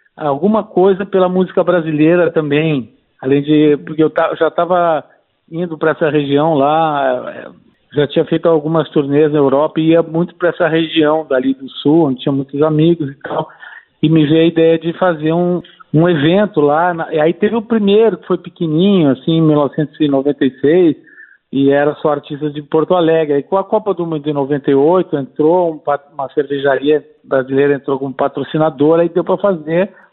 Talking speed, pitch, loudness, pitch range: 185 wpm, 160 Hz, -14 LUFS, 145-175 Hz